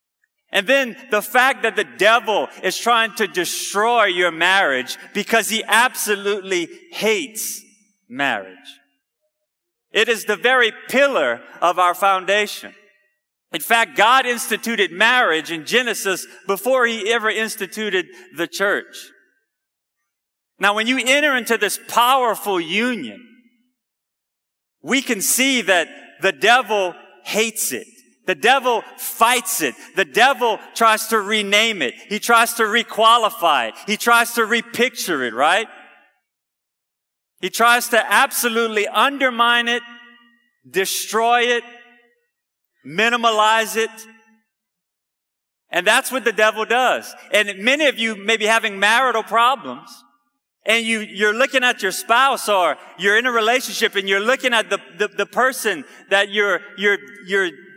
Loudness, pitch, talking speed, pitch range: -17 LUFS, 225 Hz, 130 wpm, 205-250 Hz